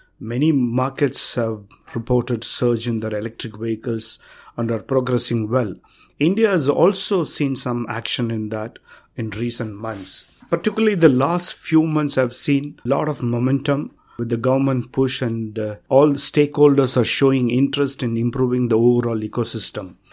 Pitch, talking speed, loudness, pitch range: 125 Hz, 150 wpm, -20 LUFS, 115-140 Hz